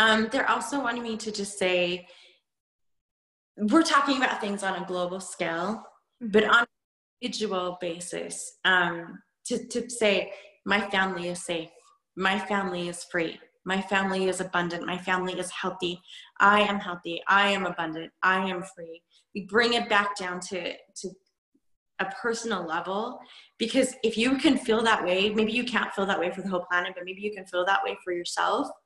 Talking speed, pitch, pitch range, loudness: 180 wpm, 195 Hz, 180-220 Hz, -27 LUFS